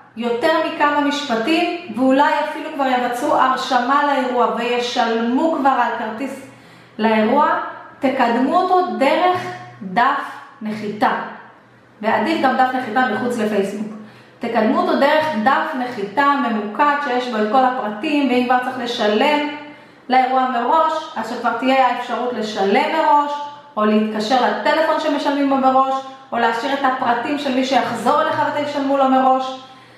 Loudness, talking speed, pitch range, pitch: -18 LUFS, 130 wpm, 235-290 Hz, 260 Hz